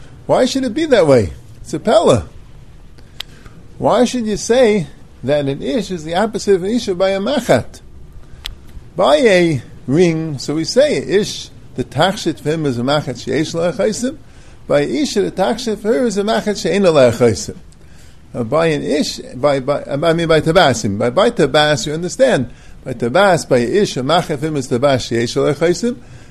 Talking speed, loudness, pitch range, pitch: 180 wpm, -15 LUFS, 130-195 Hz, 155 Hz